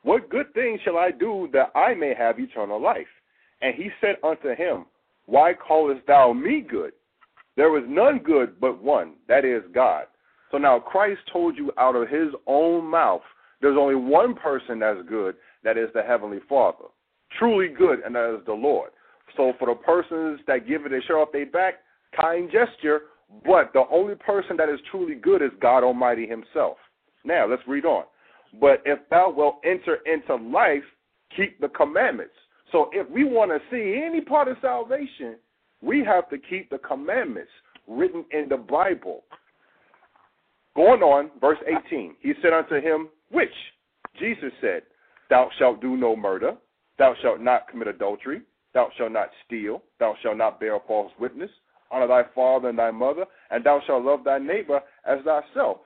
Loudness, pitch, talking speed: -23 LUFS, 160 Hz, 175 wpm